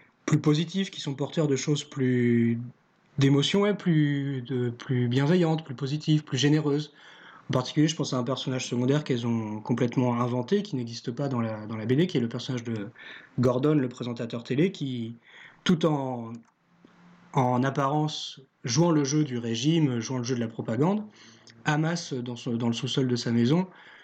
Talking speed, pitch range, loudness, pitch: 175 wpm, 125-150 Hz, -27 LUFS, 135 Hz